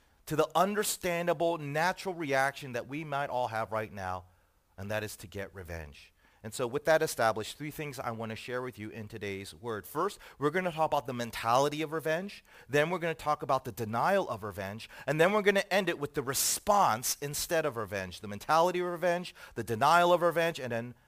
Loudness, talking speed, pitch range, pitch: -31 LUFS, 220 wpm, 110-160 Hz, 140 Hz